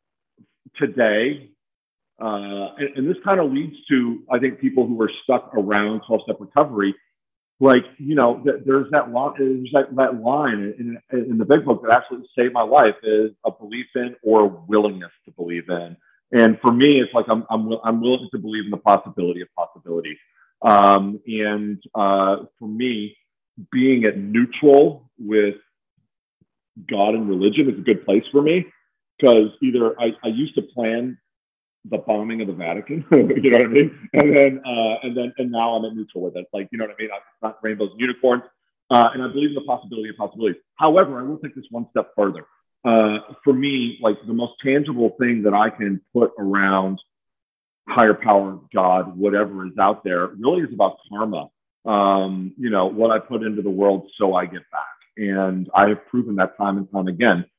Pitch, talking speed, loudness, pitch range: 110 Hz, 195 wpm, -19 LUFS, 100-125 Hz